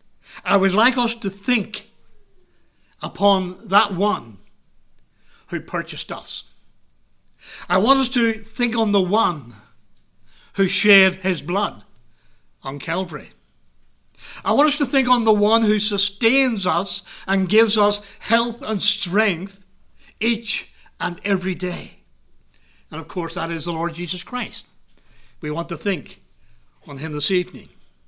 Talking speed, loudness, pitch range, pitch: 135 wpm, -20 LUFS, 170-220 Hz, 195 Hz